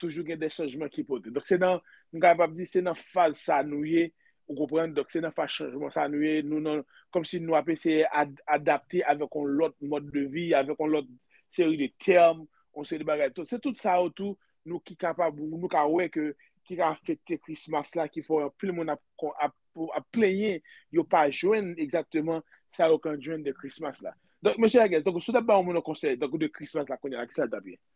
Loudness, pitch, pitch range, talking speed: -28 LUFS, 165 Hz, 150-180 Hz, 230 wpm